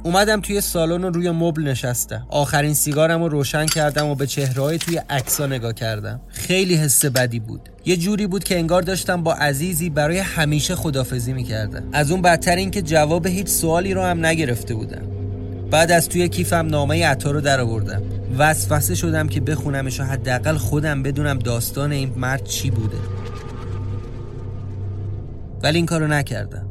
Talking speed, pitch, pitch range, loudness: 160 wpm, 145 Hz, 115-165 Hz, -20 LUFS